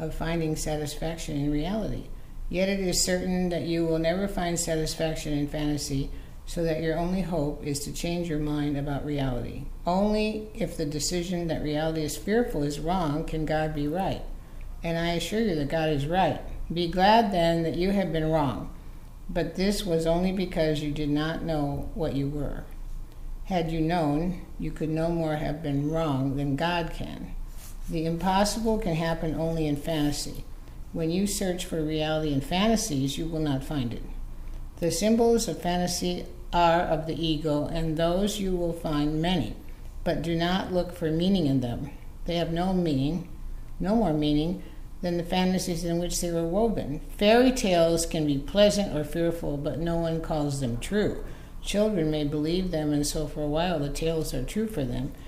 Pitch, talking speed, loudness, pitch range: 160 Hz, 180 wpm, -27 LUFS, 150-175 Hz